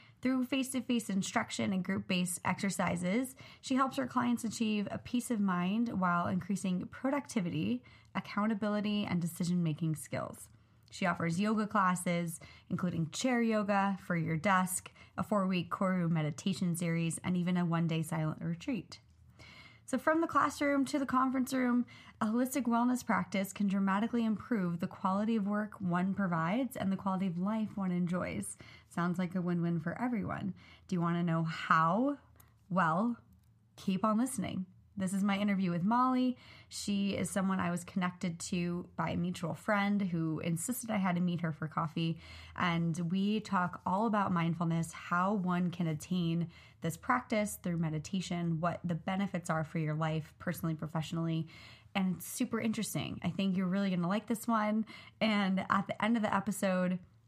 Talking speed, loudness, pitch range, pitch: 170 wpm, -34 LUFS, 170-215 Hz, 190 Hz